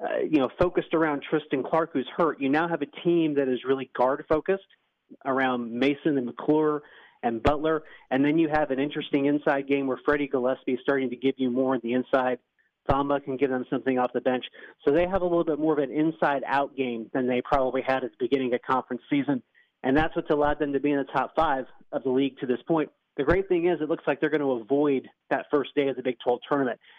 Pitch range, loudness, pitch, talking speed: 130-155 Hz, -26 LUFS, 140 Hz, 245 wpm